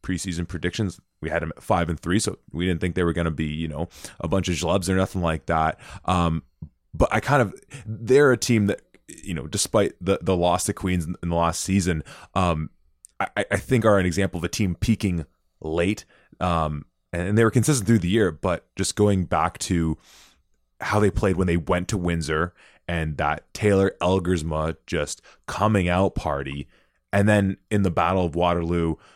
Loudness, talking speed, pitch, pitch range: -24 LUFS, 200 wpm, 90 Hz, 80-100 Hz